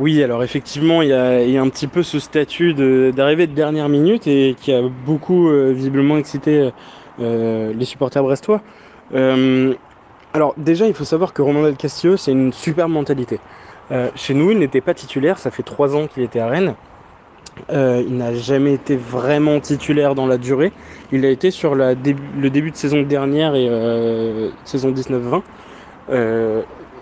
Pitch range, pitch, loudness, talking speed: 130-150 Hz, 140 Hz, -17 LUFS, 185 wpm